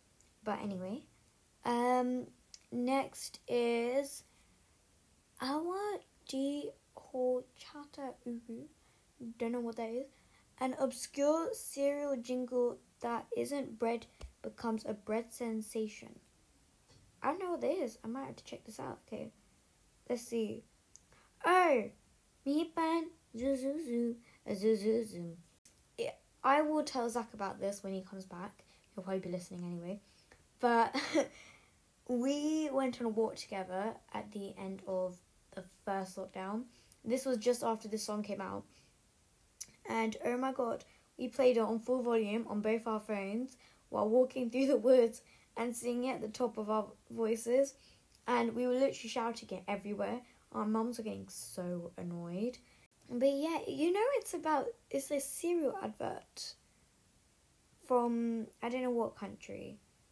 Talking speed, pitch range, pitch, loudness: 135 wpm, 210-270 Hz, 235 Hz, -36 LUFS